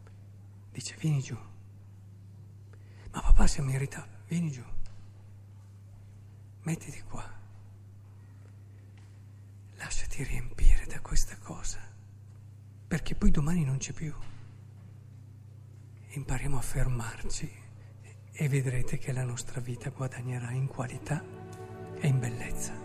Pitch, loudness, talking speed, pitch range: 105 Hz, -34 LUFS, 95 wpm, 100-130 Hz